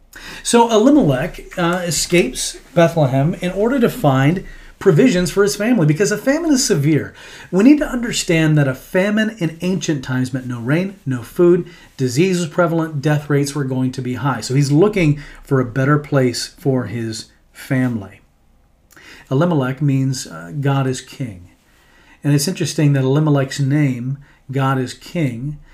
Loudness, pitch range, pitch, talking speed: -17 LUFS, 130-175 Hz, 145 Hz, 160 wpm